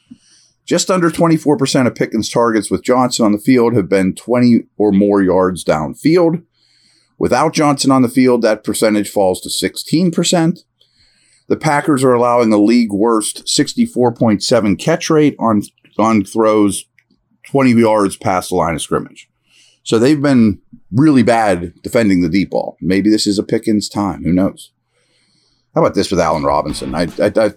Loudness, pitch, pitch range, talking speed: -14 LUFS, 115 Hz, 105-145 Hz, 165 wpm